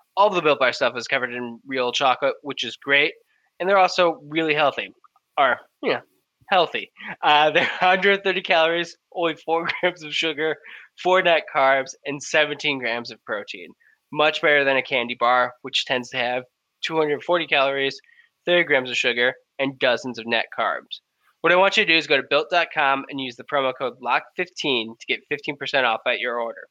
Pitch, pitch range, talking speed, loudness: 150 Hz, 130-170 Hz, 185 wpm, -21 LUFS